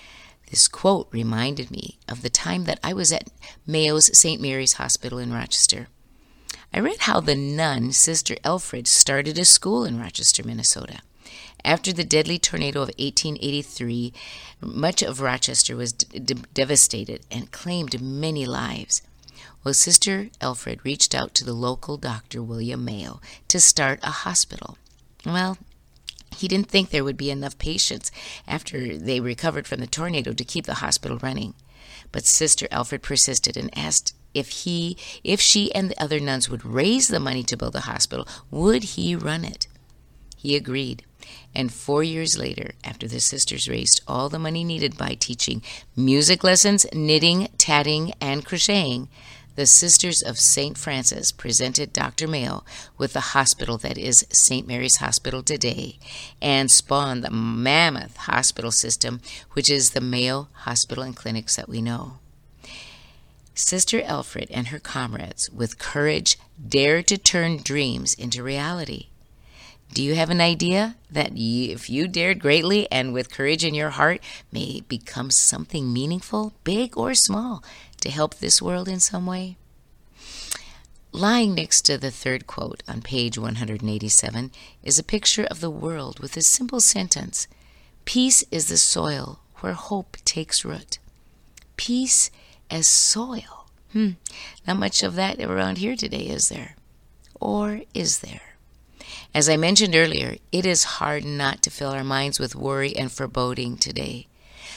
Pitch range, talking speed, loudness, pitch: 125-170 Hz, 155 wpm, -20 LUFS, 140 Hz